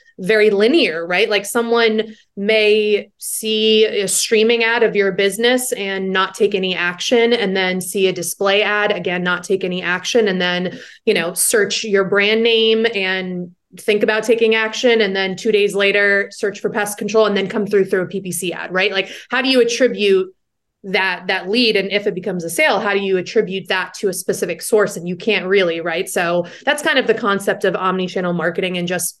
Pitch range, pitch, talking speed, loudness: 185-220 Hz, 200 Hz, 205 wpm, -16 LUFS